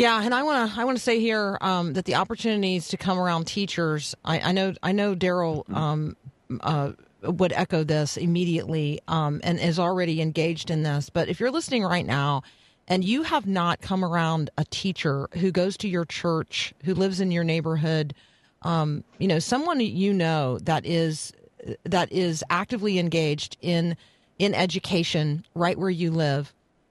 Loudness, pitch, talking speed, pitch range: -25 LUFS, 170 Hz, 180 wpm, 155-190 Hz